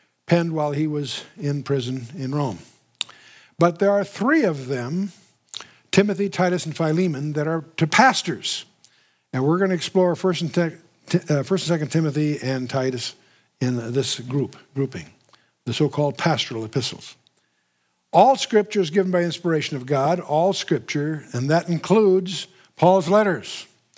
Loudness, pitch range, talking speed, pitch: -22 LUFS, 140-185 Hz, 140 wpm, 160 Hz